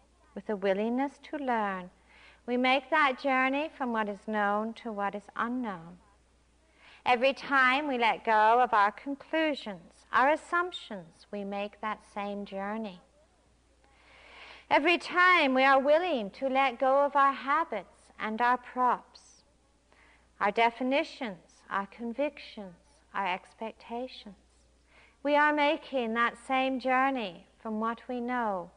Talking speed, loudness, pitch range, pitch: 130 wpm, -29 LUFS, 205-275 Hz, 245 Hz